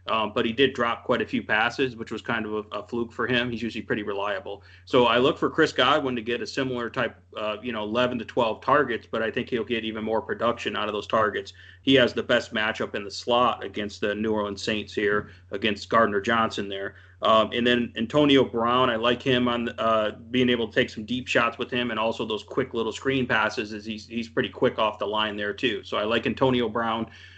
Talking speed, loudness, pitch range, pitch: 245 wpm, -25 LUFS, 105-120 Hz, 115 Hz